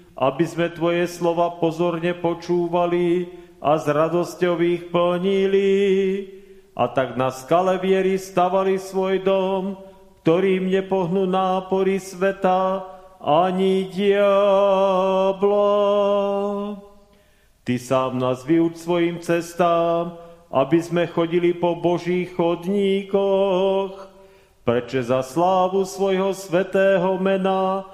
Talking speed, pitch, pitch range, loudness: 90 wpm, 185 Hz, 170-195 Hz, -21 LUFS